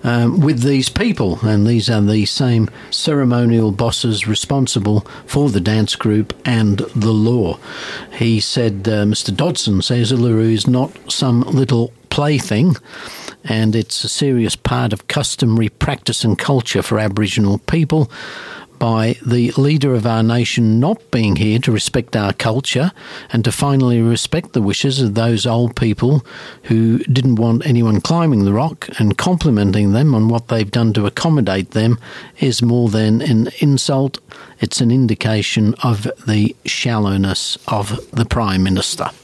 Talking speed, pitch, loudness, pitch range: 150 wpm, 115 Hz, -16 LUFS, 110-130 Hz